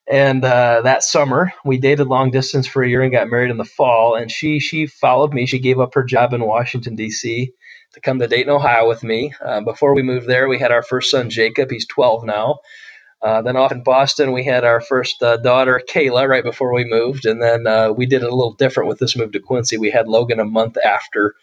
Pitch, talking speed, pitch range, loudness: 125 Hz, 245 wpm, 115-130 Hz, -16 LUFS